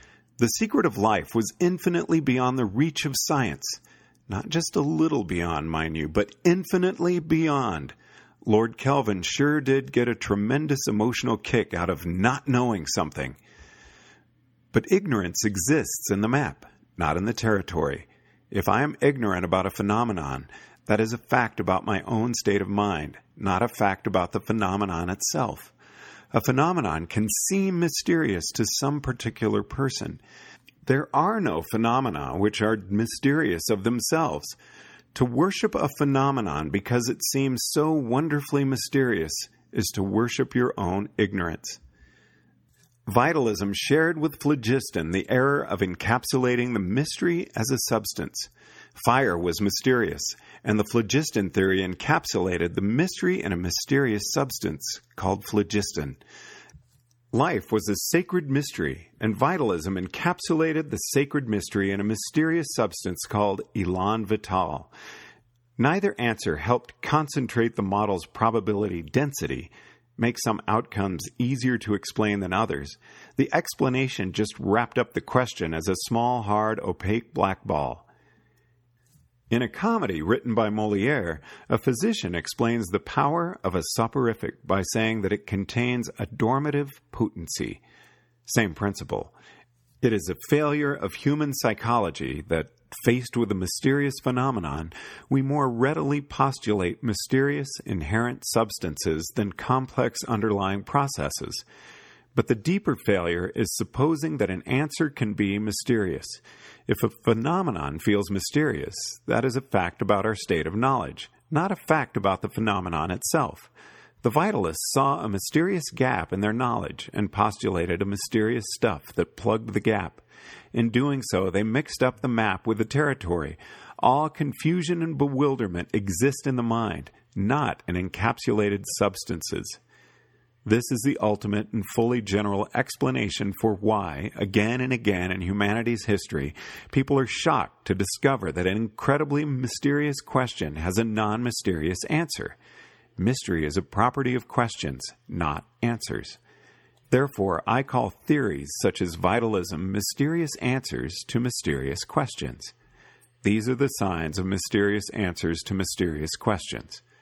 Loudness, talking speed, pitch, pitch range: -26 LUFS, 140 wpm, 115 Hz, 100-135 Hz